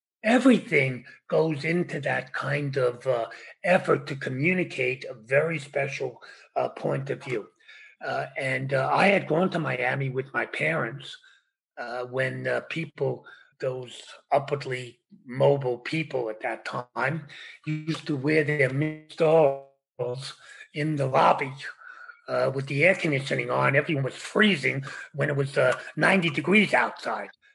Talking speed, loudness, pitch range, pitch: 135 wpm, -26 LUFS, 130-170 Hz, 145 Hz